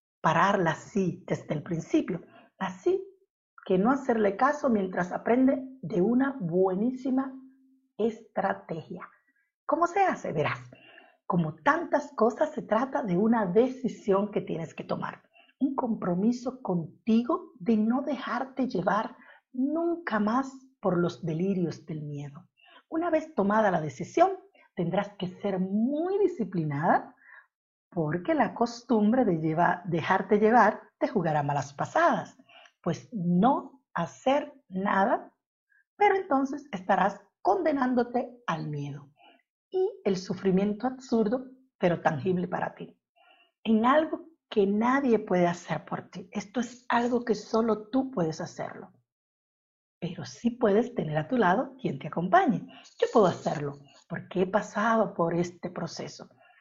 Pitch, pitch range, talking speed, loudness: 220 Hz, 180-265 Hz, 125 wpm, -28 LUFS